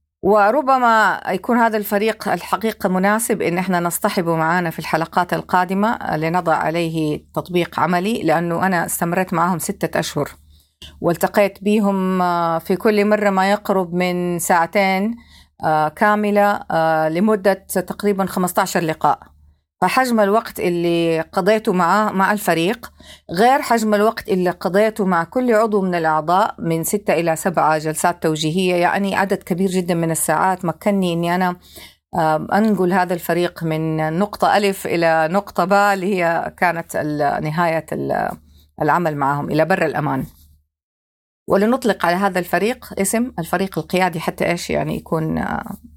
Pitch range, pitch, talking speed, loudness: 165-200 Hz, 180 Hz, 130 wpm, -18 LUFS